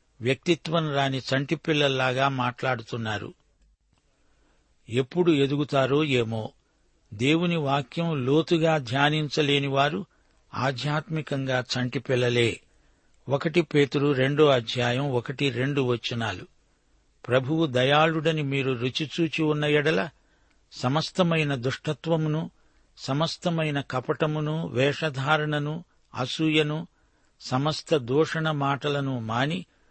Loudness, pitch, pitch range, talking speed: -25 LUFS, 140 Hz, 130-155 Hz, 75 wpm